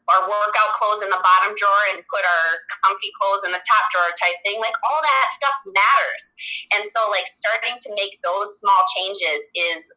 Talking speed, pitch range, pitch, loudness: 200 wpm, 185-225 Hz, 205 Hz, -19 LUFS